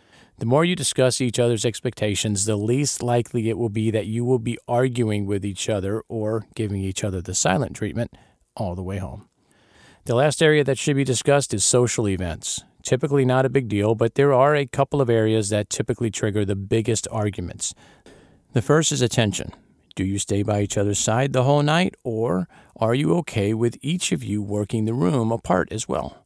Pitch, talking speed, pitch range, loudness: 115 Hz, 200 wpm, 105-130 Hz, -22 LUFS